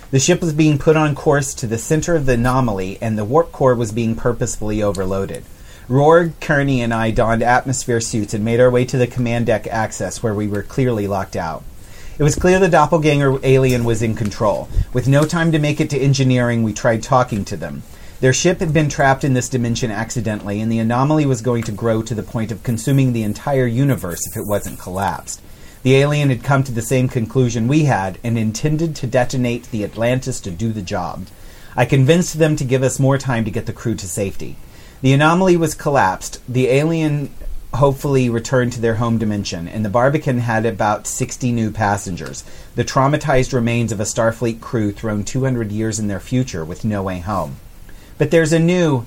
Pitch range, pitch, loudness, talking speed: 110-135 Hz, 120 Hz, -17 LUFS, 205 wpm